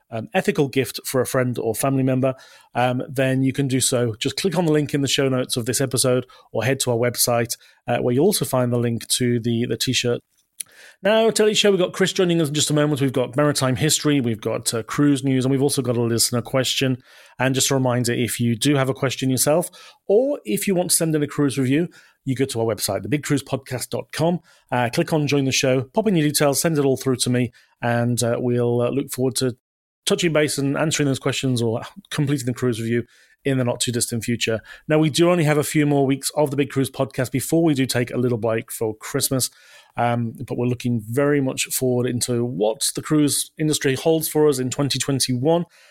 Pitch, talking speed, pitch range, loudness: 135 Hz, 235 wpm, 120-150 Hz, -21 LUFS